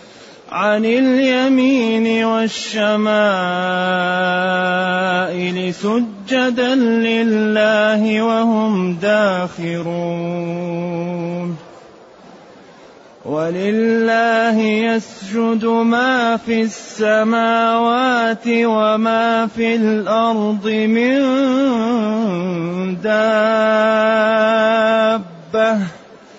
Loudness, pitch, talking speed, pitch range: -16 LUFS, 220 Hz, 40 wpm, 185-230 Hz